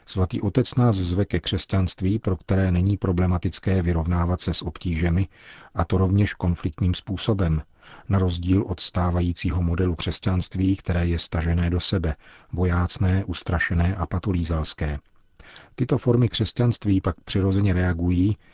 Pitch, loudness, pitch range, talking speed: 90 Hz, -23 LUFS, 85-95 Hz, 130 wpm